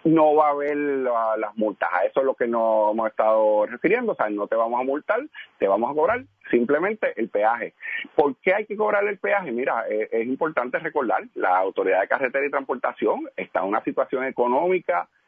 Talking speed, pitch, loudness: 205 wpm, 145 Hz, -23 LUFS